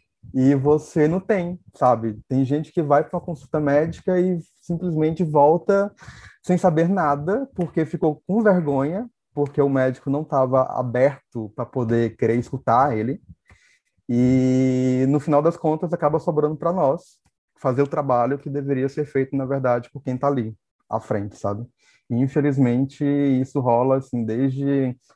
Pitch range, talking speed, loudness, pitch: 130-160 Hz, 155 wpm, -21 LUFS, 140 Hz